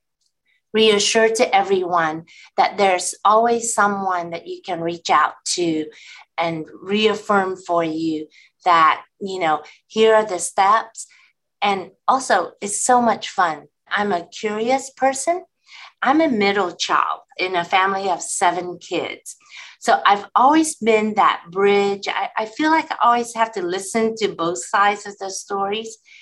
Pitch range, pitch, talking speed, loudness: 180-225 Hz, 200 Hz, 150 wpm, -19 LUFS